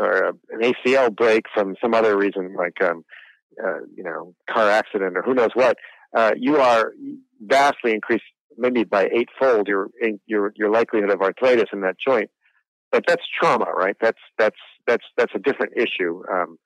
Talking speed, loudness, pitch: 175 wpm, -20 LUFS, 115 Hz